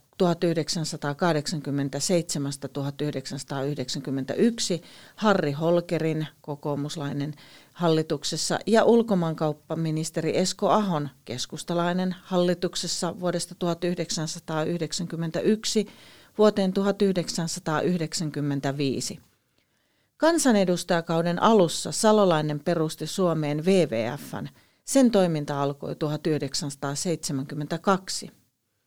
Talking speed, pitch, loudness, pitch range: 50 wpm, 165 Hz, -26 LUFS, 145-180 Hz